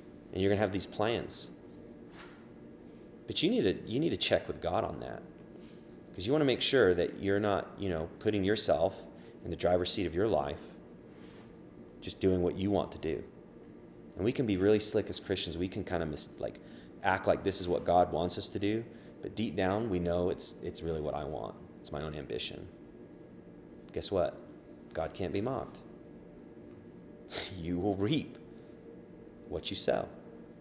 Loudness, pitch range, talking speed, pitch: -33 LUFS, 60-100 Hz, 190 wpm, 85 Hz